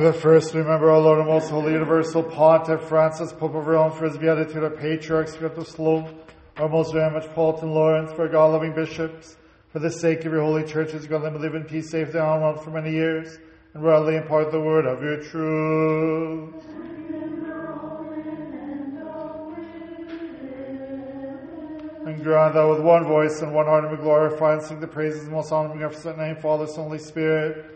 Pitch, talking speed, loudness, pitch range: 160 Hz, 185 wpm, -22 LUFS, 155-165 Hz